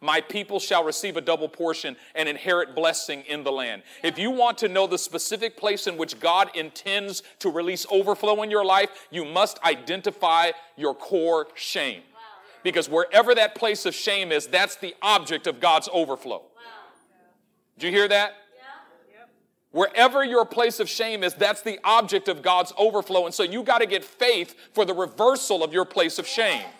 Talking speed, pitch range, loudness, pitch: 180 wpm, 170-215 Hz, -23 LUFS, 195 Hz